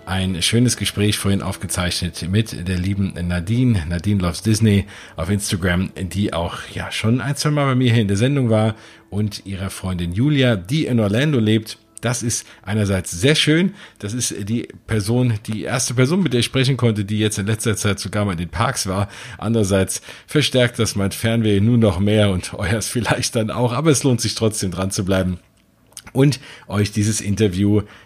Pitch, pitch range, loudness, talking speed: 110 Hz, 100-120 Hz, -19 LUFS, 190 wpm